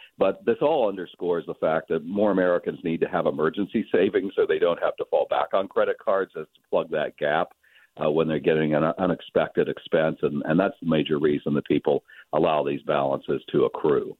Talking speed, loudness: 205 wpm, -24 LUFS